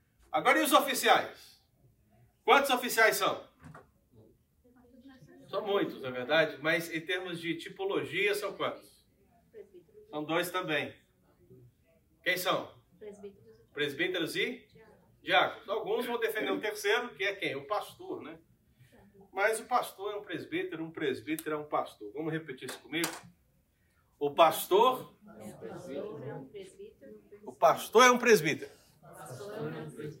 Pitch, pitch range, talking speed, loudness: 200 Hz, 155-250 Hz, 130 wpm, -30 LUFS